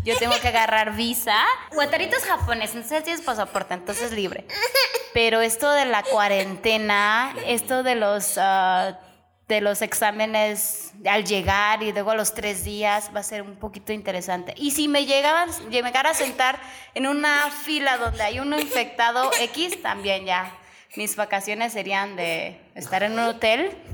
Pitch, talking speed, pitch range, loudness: 220 Hz, 160 wpm, 205-270 Hz, -22 LUFS